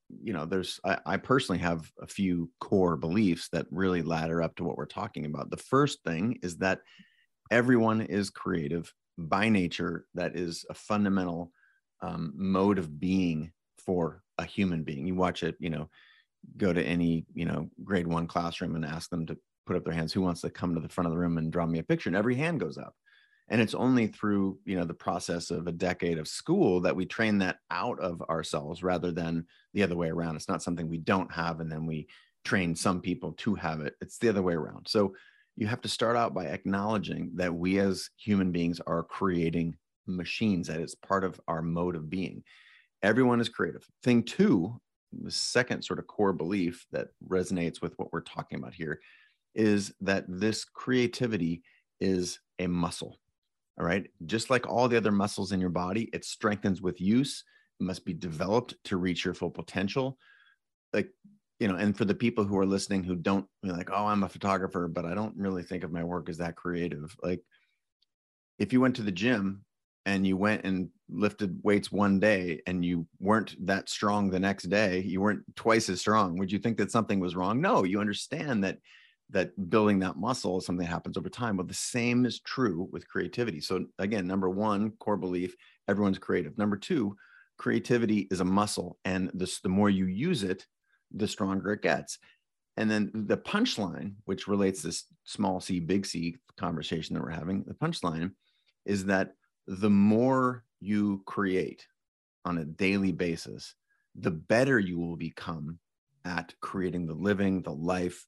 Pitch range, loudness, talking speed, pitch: 85-105 Hz, -30 LUFS, 195 wpm, 95 Hz